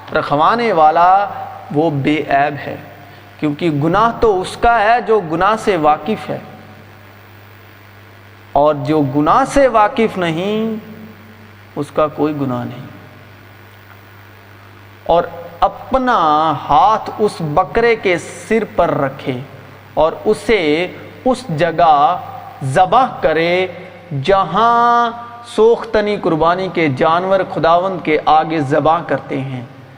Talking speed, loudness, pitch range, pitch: 110 wpm, -14 LUFS, 135-195 Hz, 160 Hz